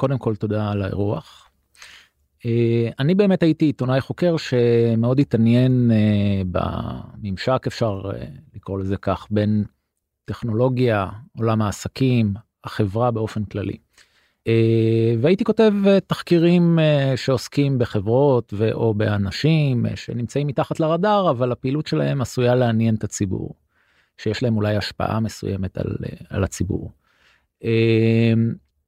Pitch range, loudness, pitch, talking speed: 105-135 Hz, -20 LUFS, 115 Hz, 120 wpm